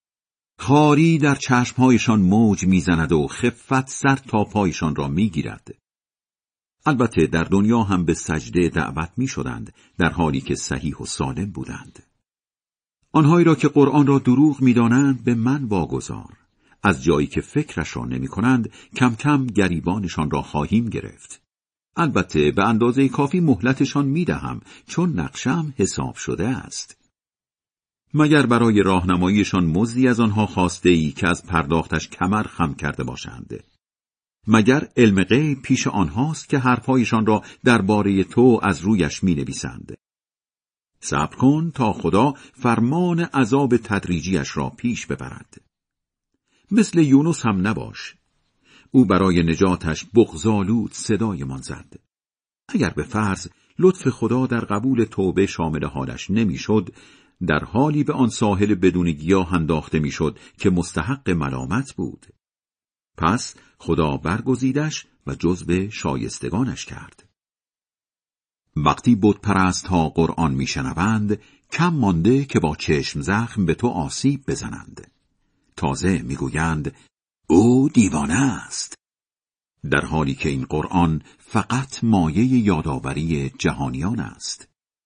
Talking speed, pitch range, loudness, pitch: 125 wpm, 85-130 Hz, -20 LUFS, 105 Hz